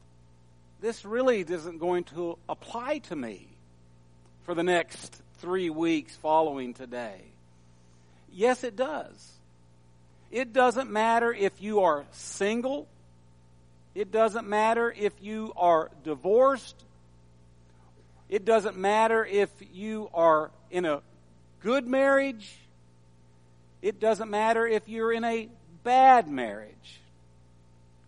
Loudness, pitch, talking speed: -27 LUFS, 170 Hz, 110 wpm